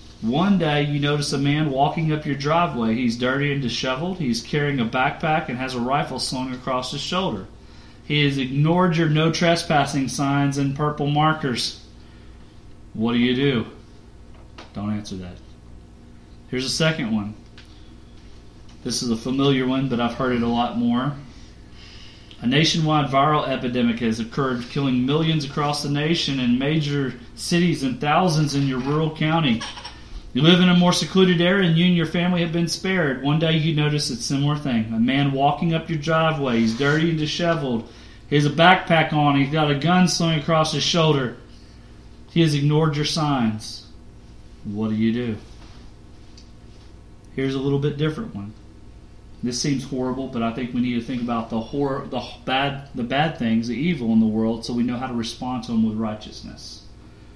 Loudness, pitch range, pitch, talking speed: -21 LUFS, 120-155 Hz, 135 Hz, 180 wpm